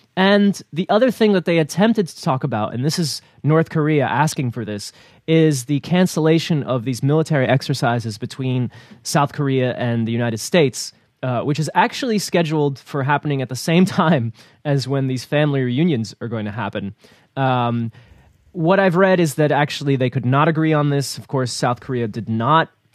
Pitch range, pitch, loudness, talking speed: 125-160 Hz, 140 Hz, -19 LUFS, 185 wpm